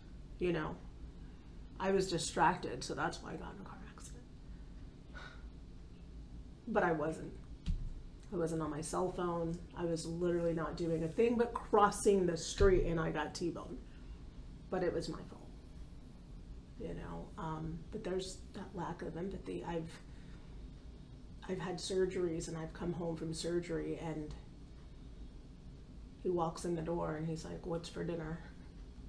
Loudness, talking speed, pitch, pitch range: -38 LUFS, 155 wpm, 165 Hz, 150-175 Hz